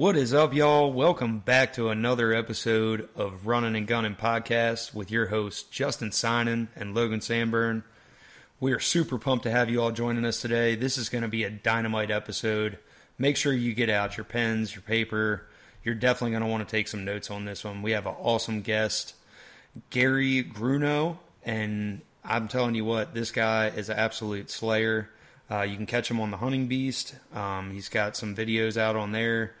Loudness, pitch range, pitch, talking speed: -27 LUFS, 110-120 Hz, 115 Hz, 195 wpm